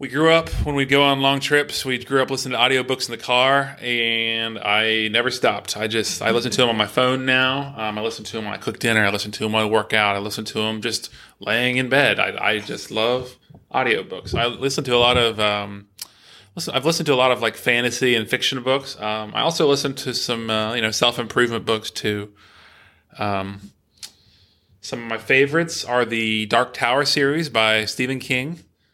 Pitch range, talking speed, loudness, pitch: 110-130 Hz, 220 wpm, -20 LUFS, 120 Hz